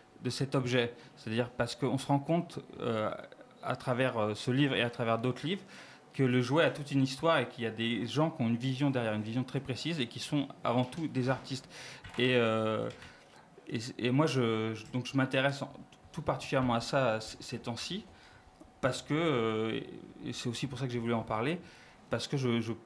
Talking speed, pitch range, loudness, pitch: 220 wpm, 120-140 Hz, -33 LUFS, 125 Hz